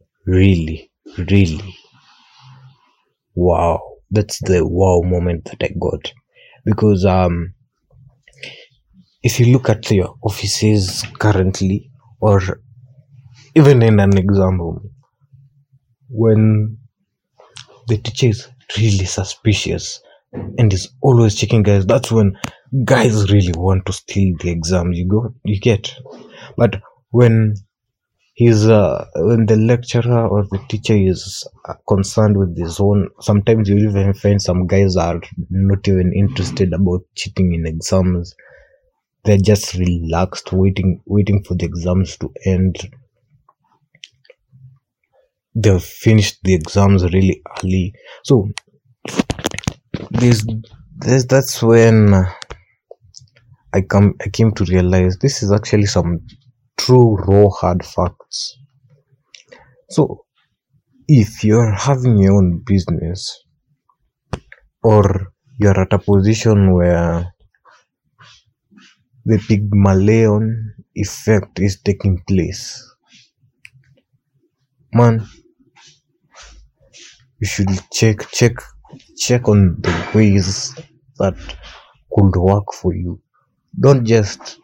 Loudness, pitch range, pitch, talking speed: -15 LUFS, 95-120 Hz, 105 Hz, 105 wpm